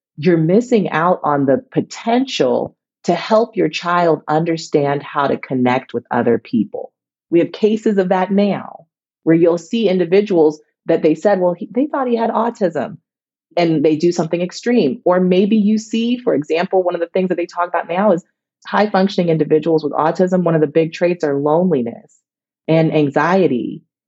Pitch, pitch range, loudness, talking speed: 175 Hz, 155-195 Hz, -16 LUFS, 180 wpm